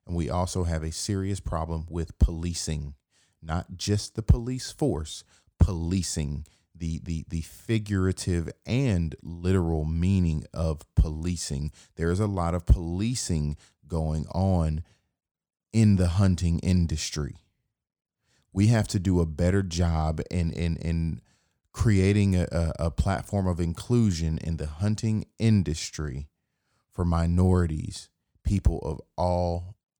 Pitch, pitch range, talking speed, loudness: 85 Hz, 80-95 Hz, 120 wpm, -27 LUFS